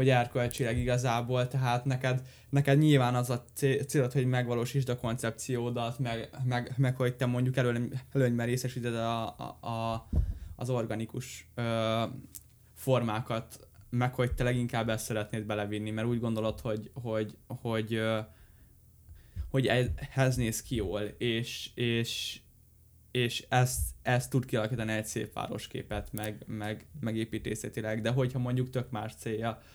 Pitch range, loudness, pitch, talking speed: 110-125 Hz, -32 LUFS, 120 Hz, 140 wpm